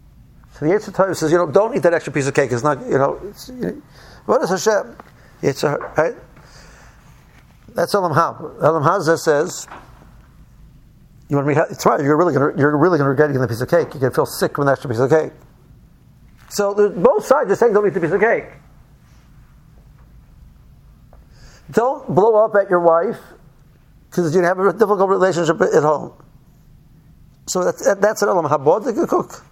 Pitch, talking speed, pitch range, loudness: 165 Hz, 185 wpm, 145-195 Hz, -17 LUFS